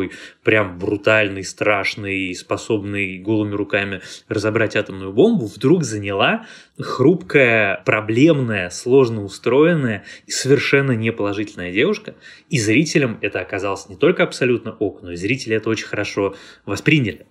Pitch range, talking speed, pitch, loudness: 100-125 Hz, 120 wpm, 110 Hz, -18 LUFS